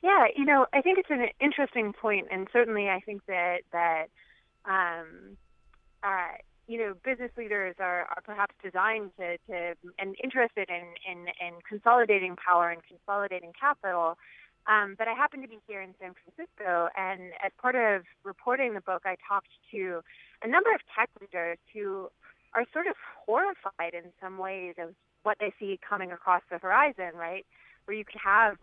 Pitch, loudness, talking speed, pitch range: 195 Hz, -29 LUFS, 175 wpm, 175-225 Hz